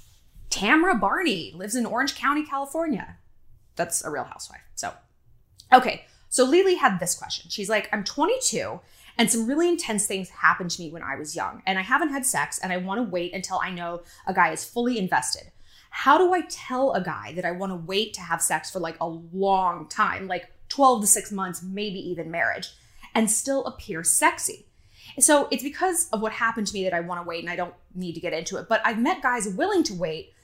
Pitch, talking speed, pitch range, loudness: 205 Hz, 220 wpm, 175-270 Hz, -24 LUFS